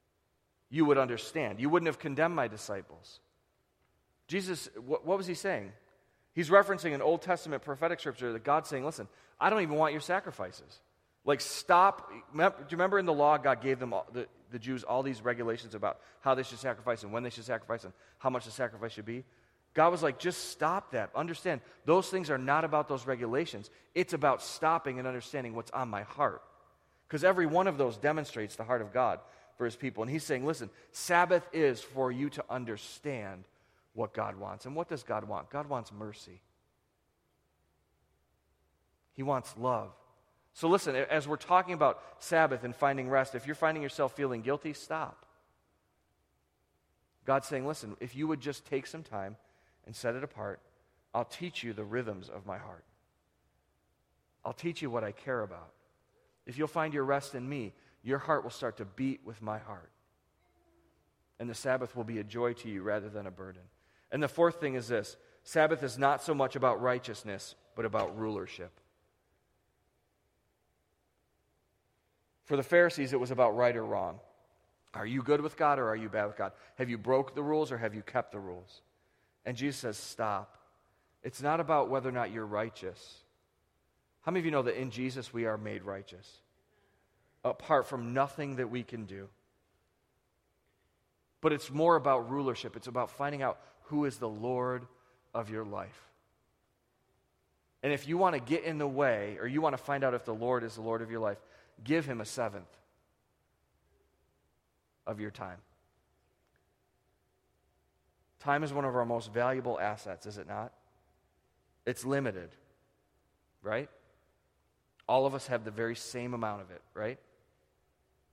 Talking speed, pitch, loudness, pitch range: 180 wpm, 125 Hz, -33 LUFS, 105-145 Hz